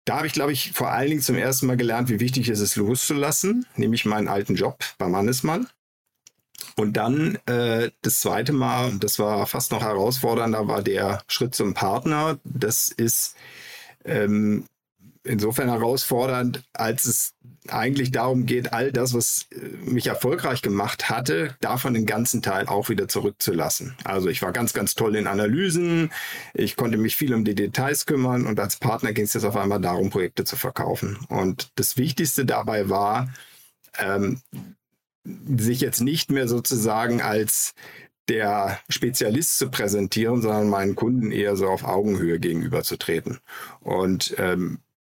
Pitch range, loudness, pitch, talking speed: 105-130 Hz, -23 LUFS, 120 Hz, 155 wpm